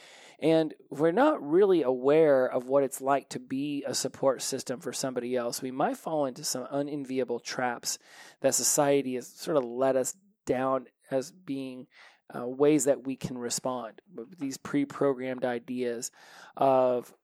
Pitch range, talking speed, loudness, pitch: 130-145 Hz, 155 wpm, -29 LUFS, 135 Hz